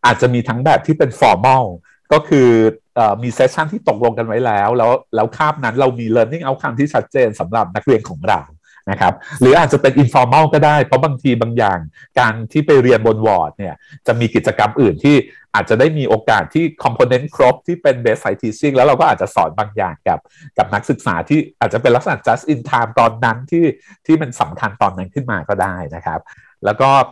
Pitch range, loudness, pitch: 120-155 Hz, -15 LUFS, 135 Hz